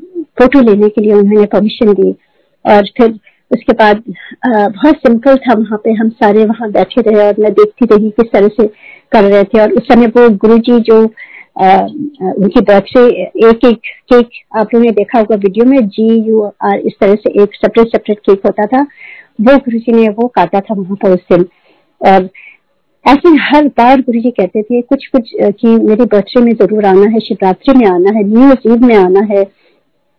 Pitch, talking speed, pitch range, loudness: 220 Hz, 195 wpm, 205-245 Hz, -8 LUFS